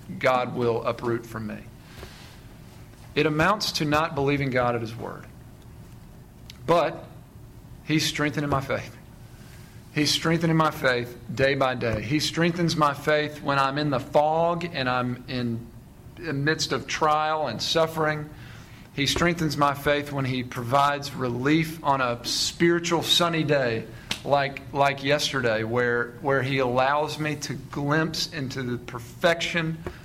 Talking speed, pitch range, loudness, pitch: 140 wpm, 125-155 Hz, -24 LUFS, 140 Hz